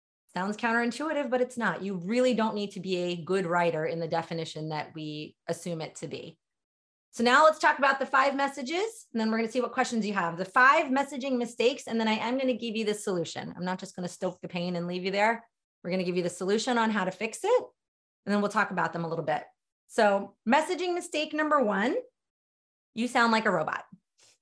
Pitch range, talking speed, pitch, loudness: 180-255 Hz, 240 wpm, 220 Hz, -28 LUFS